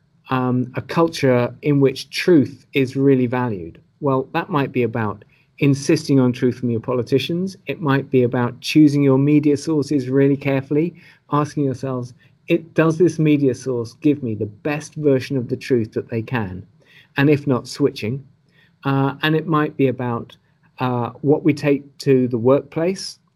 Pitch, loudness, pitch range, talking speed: 140 Hz, -19 LUFS, 125-150 Hz, 165 wpm